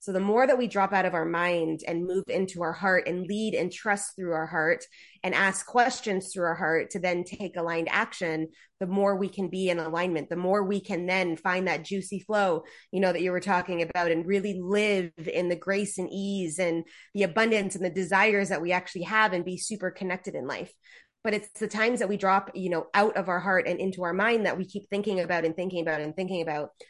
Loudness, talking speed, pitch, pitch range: -27 LUFS, 240 wpm, 185 Hz, 175-200 Hz